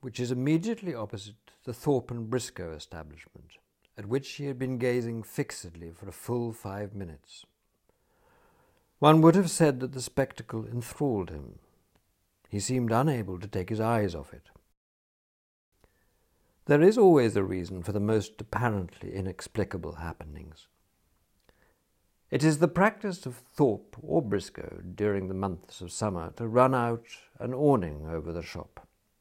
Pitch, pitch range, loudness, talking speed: 105 Hz, 90-125 Hz, -28 LUFS, 145 wpm